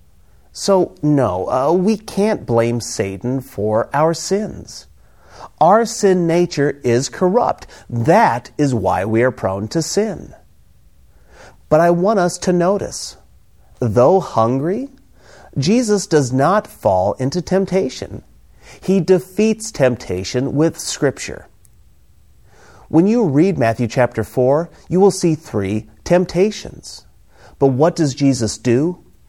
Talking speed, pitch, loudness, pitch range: 120 wpm, 150 Hz, -17 LUFS, 115-185 Hz